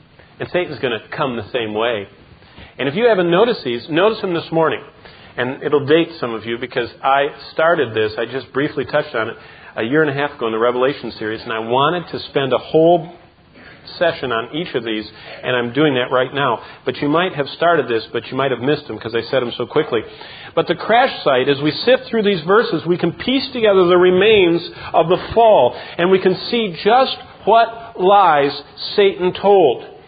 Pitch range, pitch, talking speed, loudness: 125-190 Hz, 155 Hz, 215 wpm, -17 LUFS